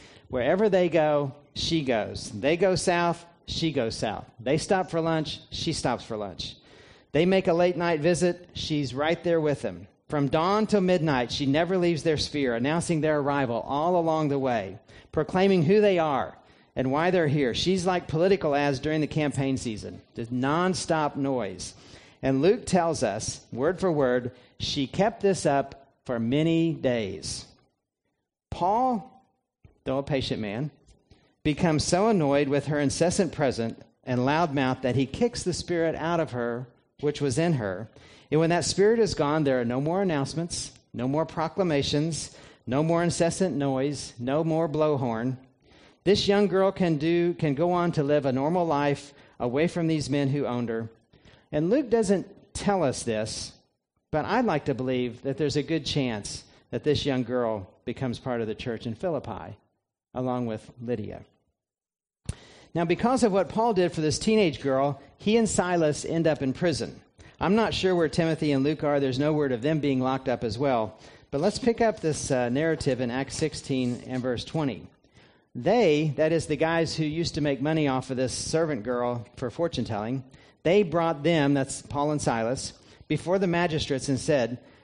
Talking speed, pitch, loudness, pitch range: 180 wpm, 145 Hz, -26 LUFS, 130-170 Hz